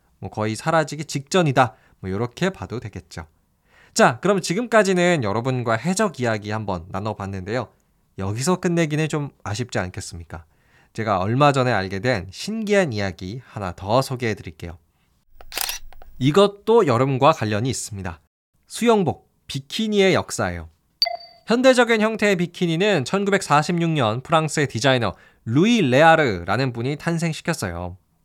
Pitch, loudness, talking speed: 130 Hz, -21 LUFS, 310 characters per minute